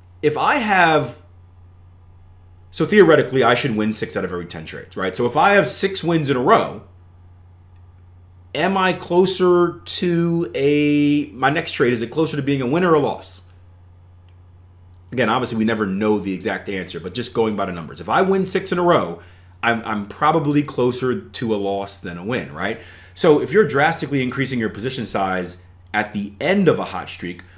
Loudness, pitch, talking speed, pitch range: -19 LUFS, 105 Hz, 195 wpm, 90-150 Hz